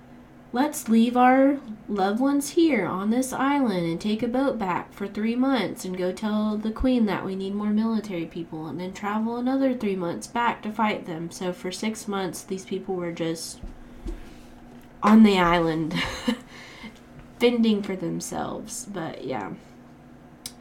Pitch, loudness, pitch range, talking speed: 210 Hz, -25 LUFS, 180-240 Hz, 155 wpm